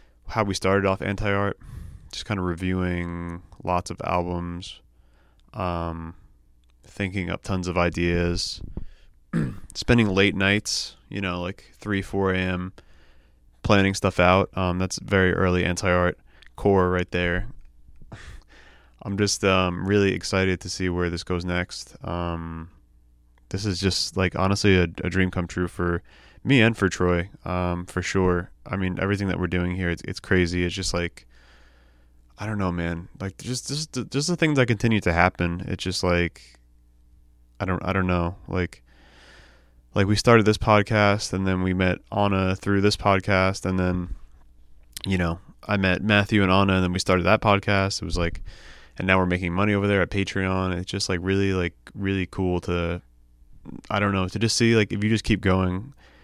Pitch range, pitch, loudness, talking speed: 85-100 Hz, 90 Hz, -24 LUFS, 175 wpm